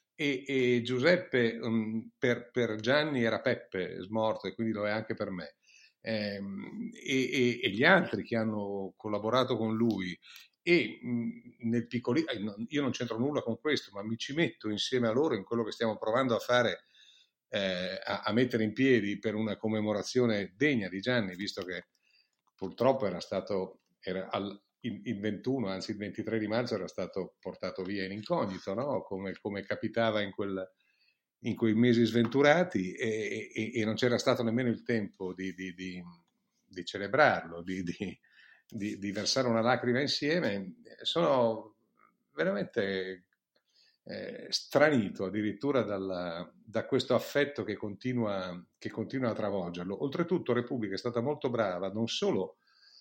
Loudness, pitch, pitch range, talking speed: -32 LUFS, 110 Hz, 100-125 Hz, 155 wpm